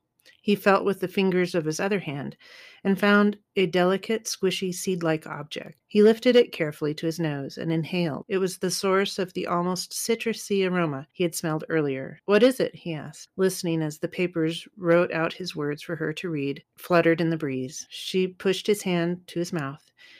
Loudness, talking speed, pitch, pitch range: -25 LUFS, 200 wpm, 180 Hz, 160-195 Hz